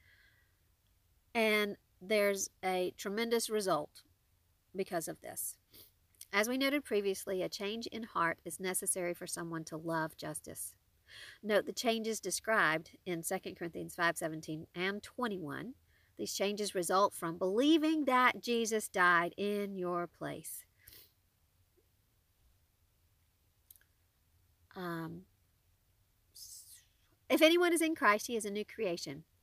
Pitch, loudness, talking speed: 175 Hz, -34 LUFS, 115 wpm